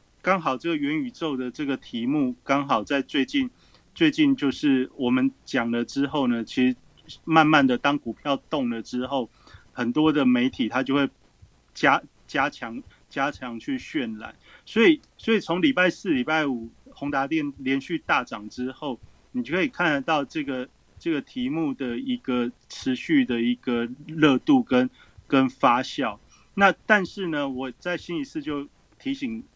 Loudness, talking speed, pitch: -24 LUFS, 235 characters per minute, 145 Hz